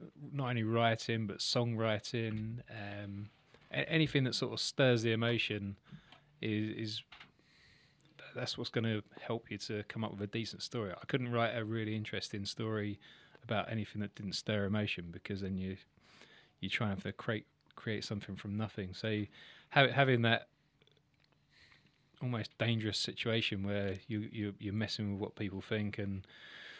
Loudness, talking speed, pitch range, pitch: -37 LUFS, 155 wpm, 100-115 Hz, 110 Hz